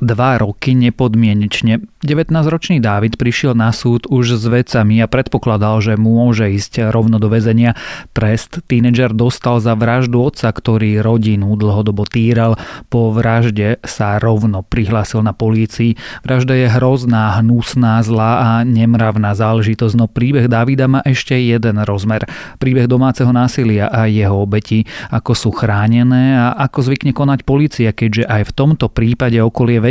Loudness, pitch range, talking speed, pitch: -13 LUFS, 110-125 Hz, 140 wpm, 115 Hz